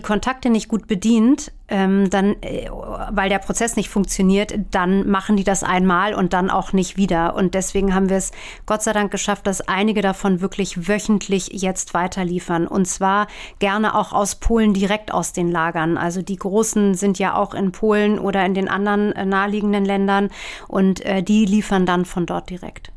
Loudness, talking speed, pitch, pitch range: -19 LUFS, 175 wpm, 195 Hz, 190-210 Hz